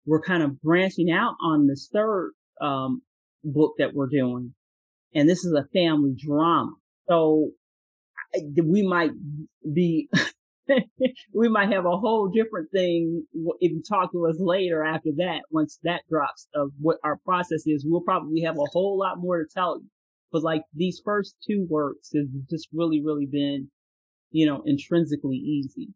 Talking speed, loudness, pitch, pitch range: 165 wpm, -25 LUFS, 160 Hz, 145-180 Hz